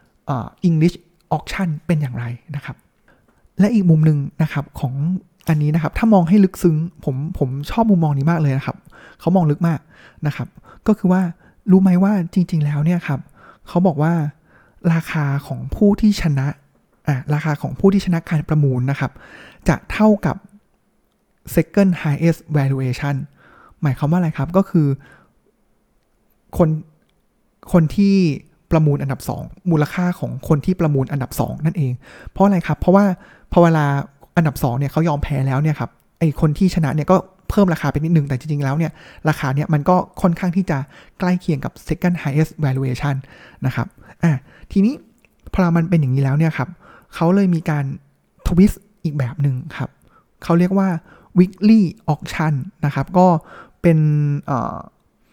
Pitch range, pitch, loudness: 145-180 Hz, 160 Hz, -18 LUFS